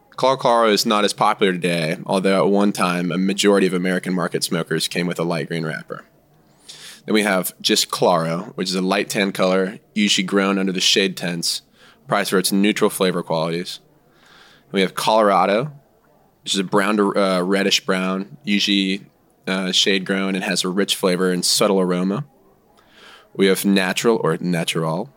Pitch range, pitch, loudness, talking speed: 90-100 Hz, 95 Hz, -19 LUFS, 180 wpm